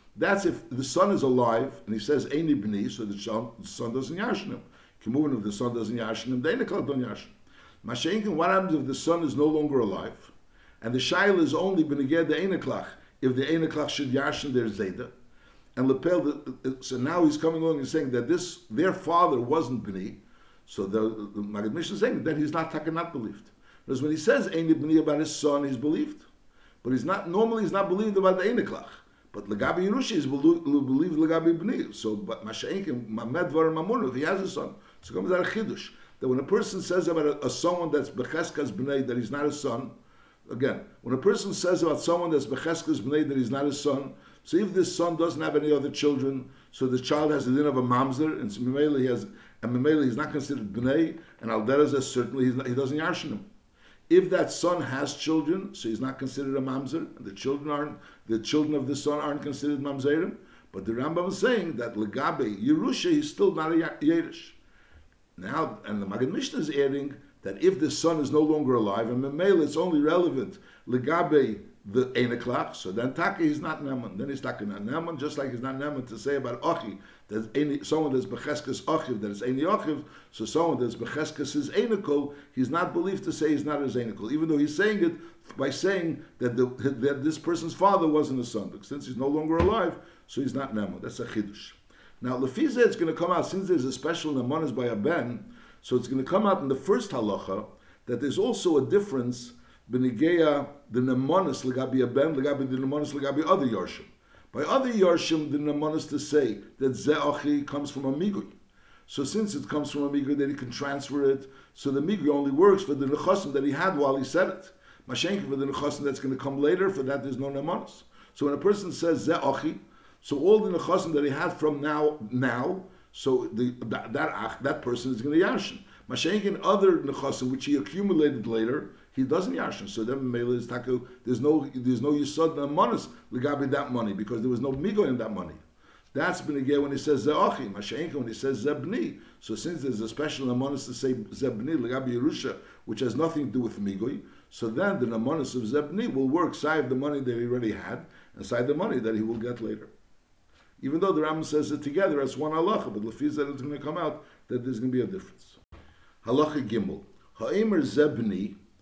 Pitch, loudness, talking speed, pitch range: 145 Hz, -28 LUFS, 215 wpm, 130-160 Hz